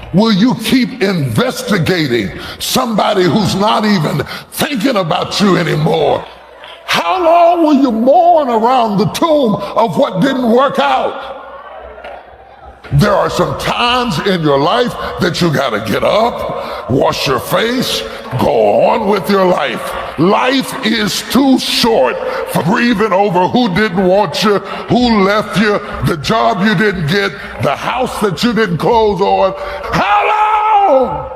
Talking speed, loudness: 140 wpm, -12 LUFS